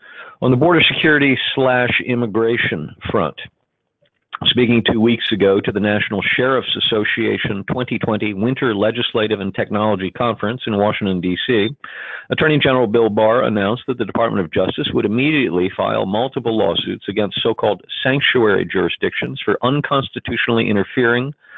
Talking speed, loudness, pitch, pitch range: 130 wpm, -17 LUFS, 115 Hz, 105-125 Hz